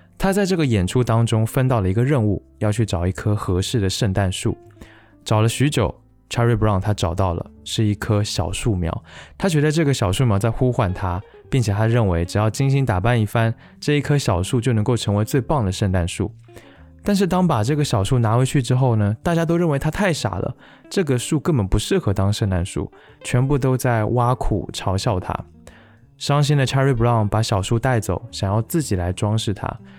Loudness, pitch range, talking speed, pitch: -20 LUFS, 100-130 Hz, 325 characters per minute, 115 Hz